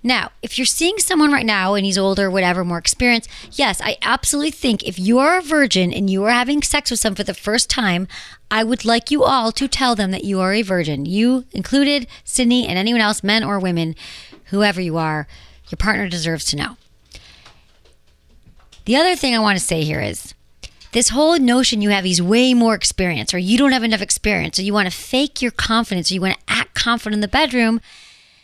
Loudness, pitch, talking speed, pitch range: -17 LUFS, 215 Hz, 210 wpm, 185-250 Hz